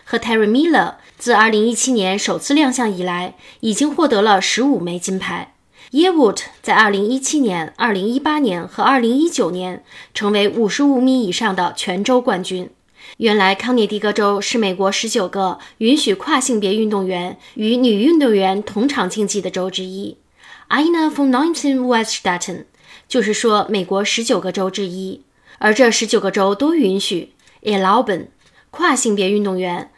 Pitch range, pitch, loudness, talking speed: 195-255 Hz, 215 Hz, -16 LUFS, 265 characters per minute